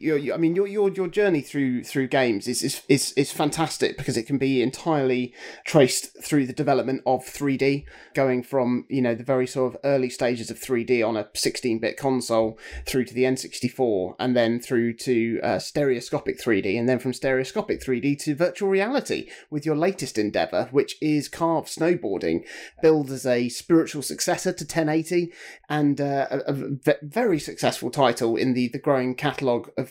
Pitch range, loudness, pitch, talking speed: 125-155 Hz, -24 LUFS, 135 Hz, 175 wpm